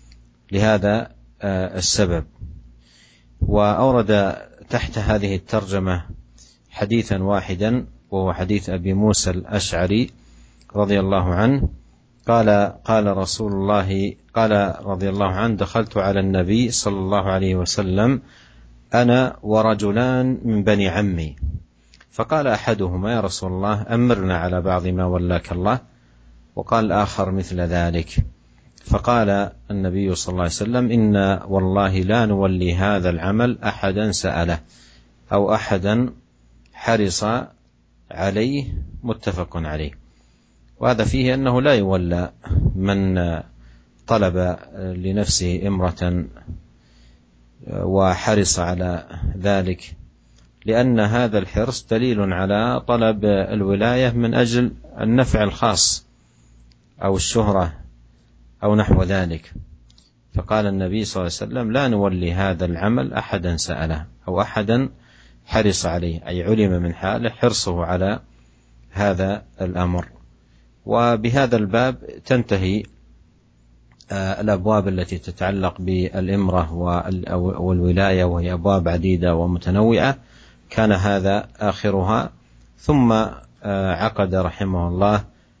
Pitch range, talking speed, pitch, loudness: 85-105 Hz, 100 wpm, 95 Hz, -20 LUFS